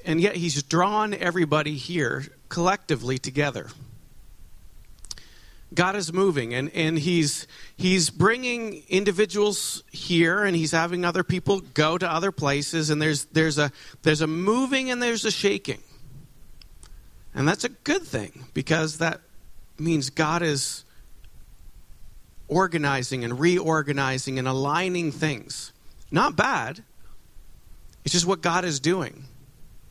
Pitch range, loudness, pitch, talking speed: 135-180 Hz, -24 LUFS, 155 Hz, 125 wpm